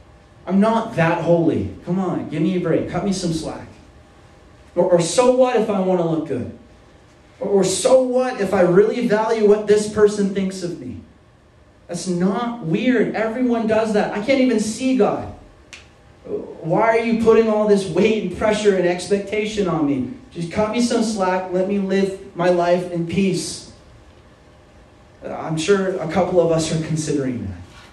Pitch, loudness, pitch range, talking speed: 185 Hz, -19 LUFS, 165-215 Hz, 180 wpm